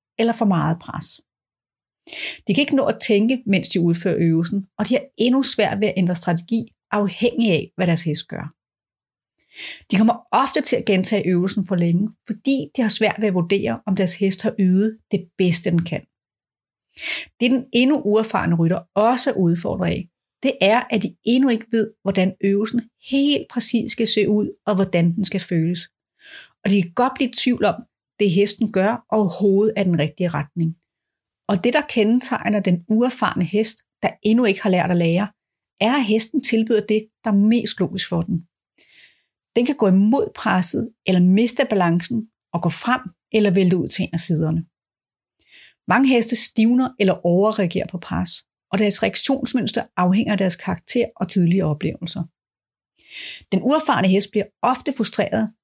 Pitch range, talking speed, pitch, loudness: 180-230 Hz, 180 wpm, 205 Hz, -19 LUFS